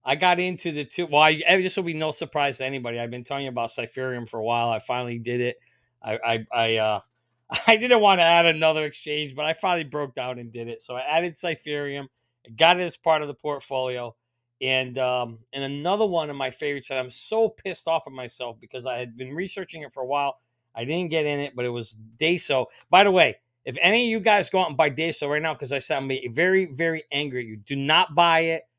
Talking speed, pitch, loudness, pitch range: 245 wpm, 140 Hz, -23 LUFS, 125-165 Hz